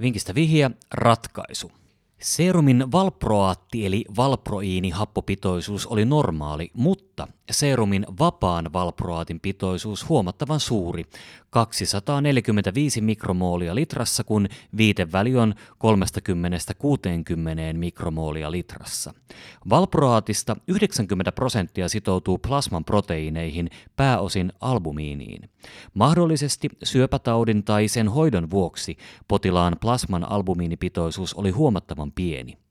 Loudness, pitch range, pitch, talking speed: -23 LUFS, 90-125 Hz, 105 Hz, 85 wpm